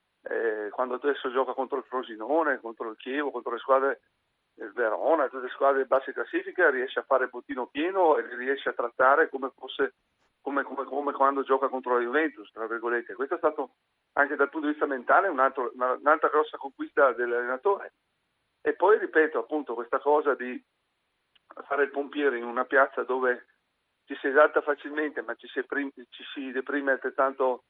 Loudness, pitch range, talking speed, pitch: -27 LUFS, 130-155 Hz, 175 wpm, 140 Hz